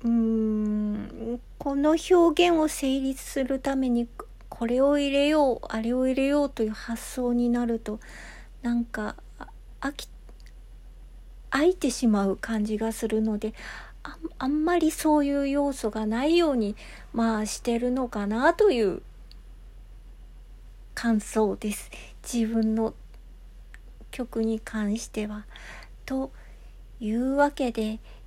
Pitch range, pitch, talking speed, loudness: 220-280 Hz, 240 Hz, 215 characters per minute, -26 LUFS